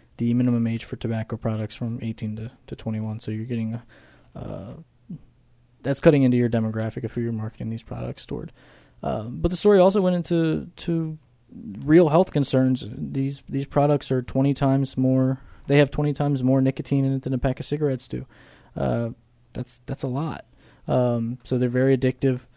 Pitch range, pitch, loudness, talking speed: 115-140 Hz, 130 Hz, -23 LUFS, 185 wpm